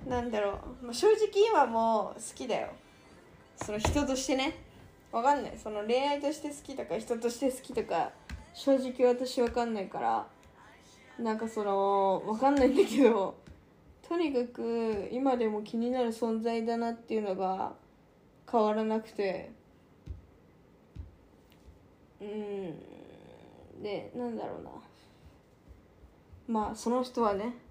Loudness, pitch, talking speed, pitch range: -31 LUFS, 230 Hz, 245 characters per minute, 210-255 Hz